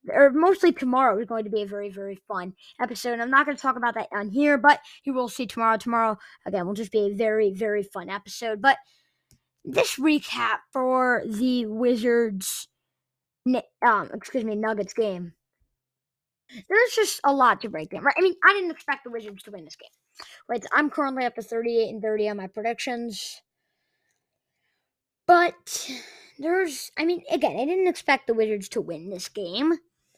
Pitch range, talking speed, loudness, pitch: 210-285 Hz, 185 wpm, -24 LUFS, 235 Hz